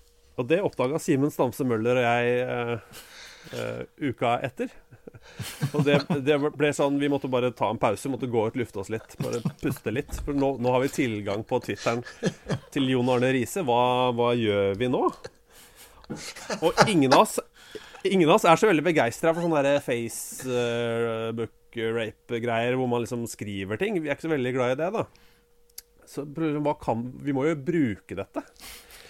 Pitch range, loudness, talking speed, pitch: 115-145 Hz, -26 LUFS, 175 wpm, 125 Hz